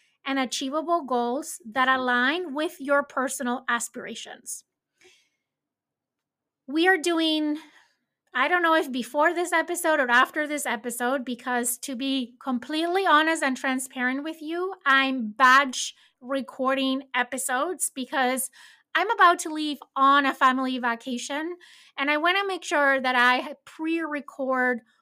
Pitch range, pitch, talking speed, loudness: 255-315 Hz, 275 Hz, 130 wpm, -24 LUFS